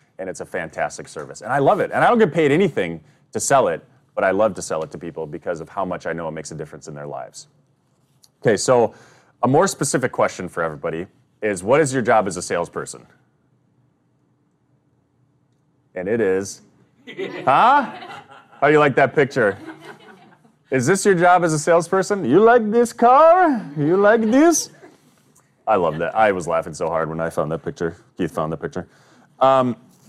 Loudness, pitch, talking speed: -18 LUFS, 140 Hz, 195 wpm